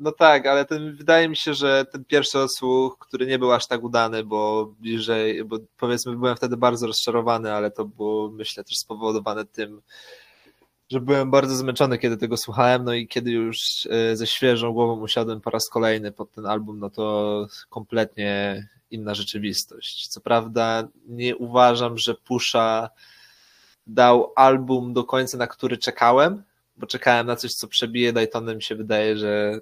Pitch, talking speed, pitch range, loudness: 120 Hz, 165 wpm, 110-125 Hz, -22 LUFS